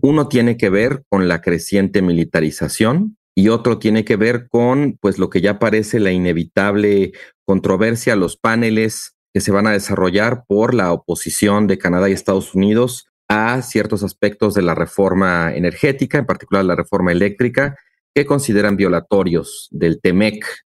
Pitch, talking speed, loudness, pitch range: 105 Hz, 155 wpm, -16 LUFS, 95-120 Hz